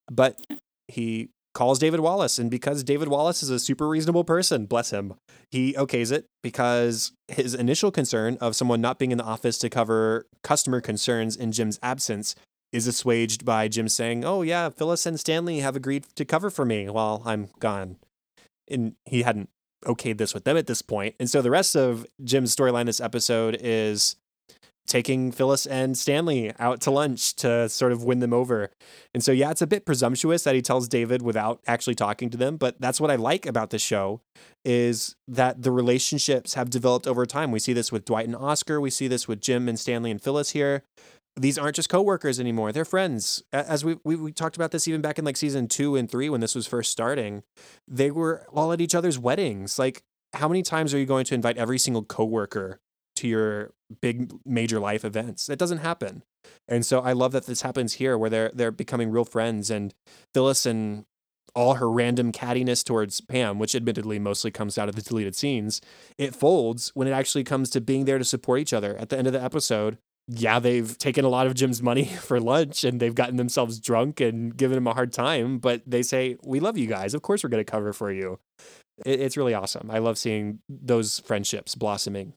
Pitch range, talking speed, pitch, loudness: 115-140 Hz, 210 wpm, 125 Hz, -25 LUFS